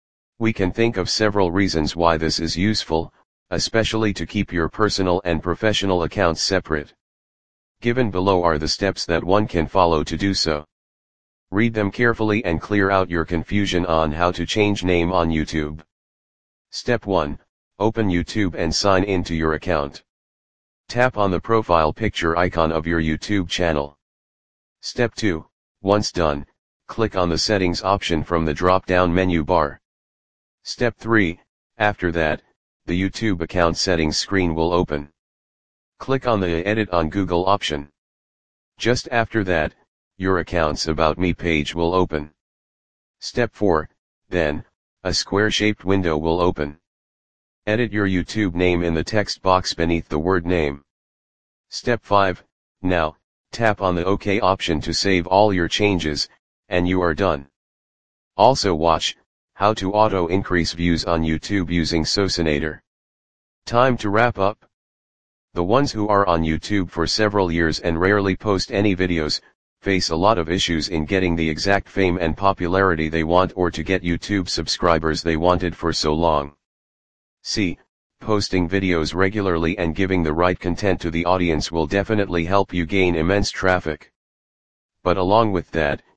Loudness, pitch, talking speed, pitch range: -20 LUFS, 90 Hz, 155 wpm, 80-100 Hz